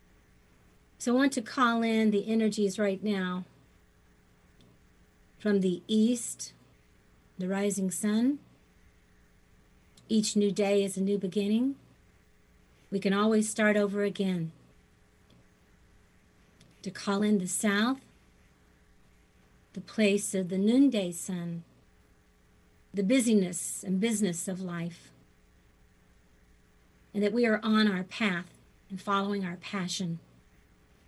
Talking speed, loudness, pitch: 110 wpm, -29 LUFS, 185 Hz